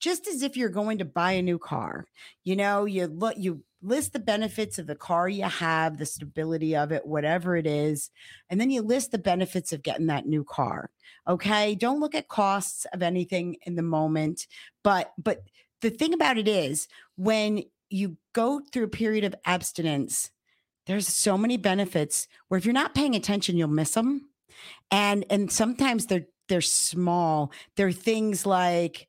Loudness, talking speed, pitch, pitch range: -27 LUFS, 180 wpm, 190 Hz, 170-220 Hz